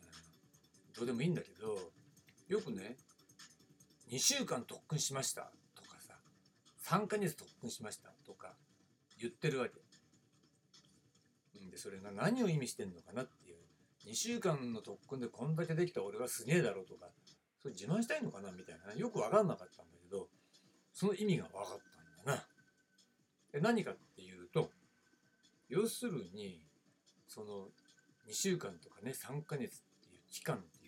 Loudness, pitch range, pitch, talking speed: -40 LUFS, 135-210 Hz, 165 Hz, 290 characters per minute